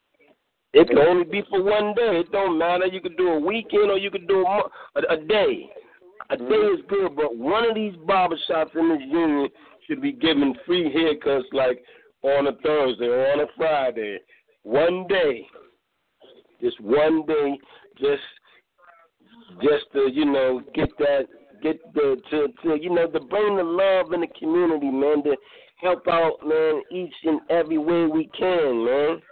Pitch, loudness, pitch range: 180 Hz, -22 LUFS, 155-230 Hz